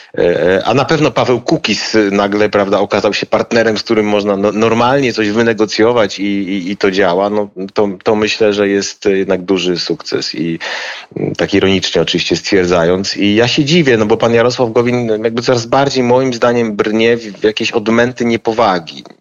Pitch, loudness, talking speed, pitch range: 115 Hz, -13 LUFS, 170 wpm, 100-120 Hz